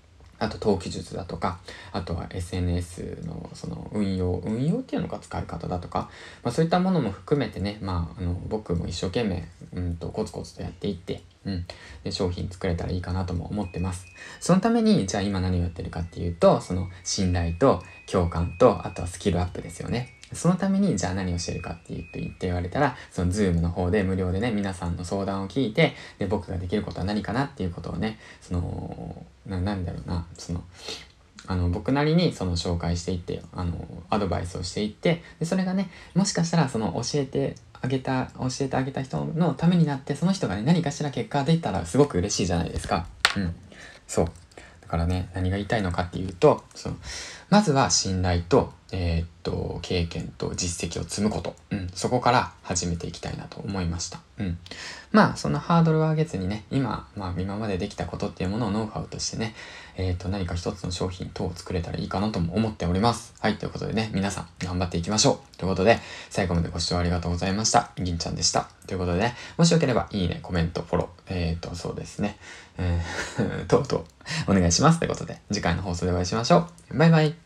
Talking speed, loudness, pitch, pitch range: 430 characters per minute, -26 LUFS, 95 Hz, 90-120 Hz